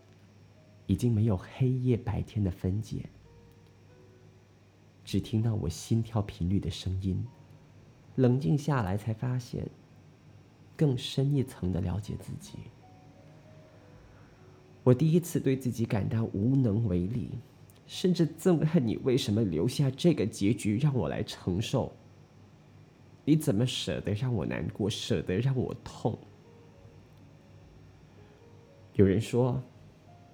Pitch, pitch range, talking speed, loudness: 115 Hz, 100-130 Hz, 170 characters per minute, -30 LUFS